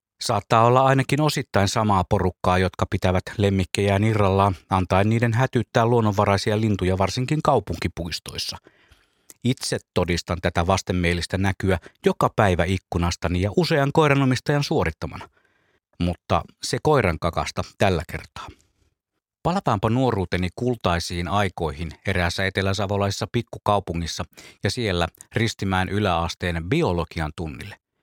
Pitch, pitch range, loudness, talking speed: 100 Hz, 90-115 Hz, -22 LUFS, 105 wpm